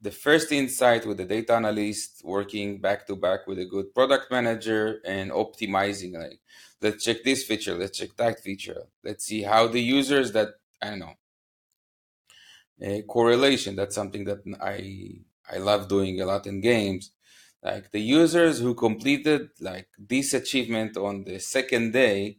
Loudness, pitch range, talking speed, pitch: -25 LUFS, 100-120 Hz, 165 wpm, 105 Hz